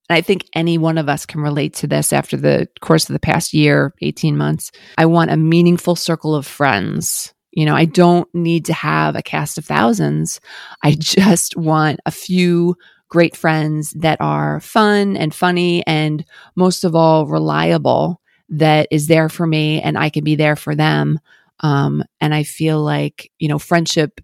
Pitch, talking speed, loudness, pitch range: 155 Hz, 185 wpm, -16 LUFS, 150-170 Hz